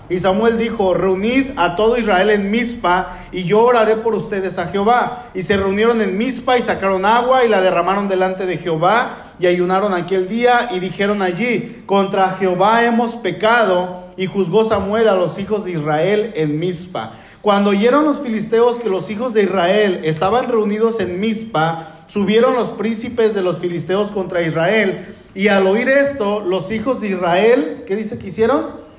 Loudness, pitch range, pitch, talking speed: -16 LUFS, 185-230 Hz, 200 Hz, 175 wpm